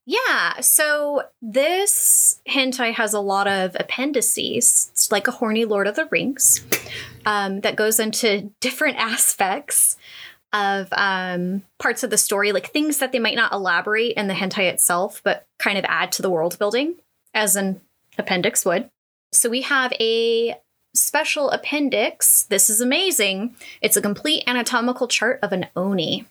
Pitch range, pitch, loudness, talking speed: 200-275 Hz, 225 Hz, -19 LUFS, 155 wpm